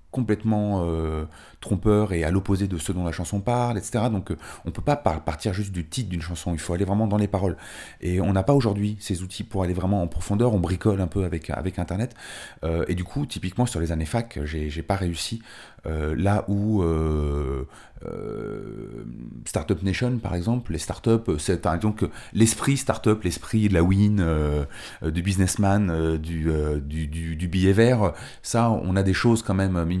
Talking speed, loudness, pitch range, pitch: 210 wpm, -25 LUFS, 85-105 Hz, 95 Hz